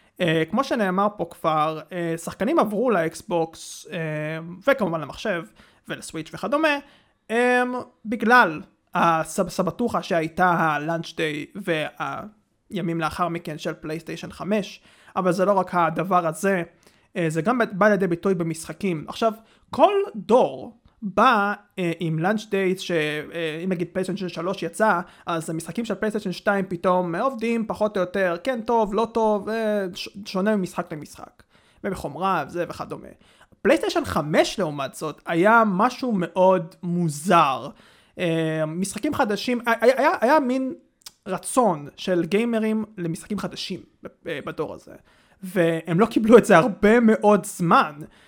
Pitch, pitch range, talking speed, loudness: 190 Hz, 170-220 Hz, 130 wpm, -23 LUFS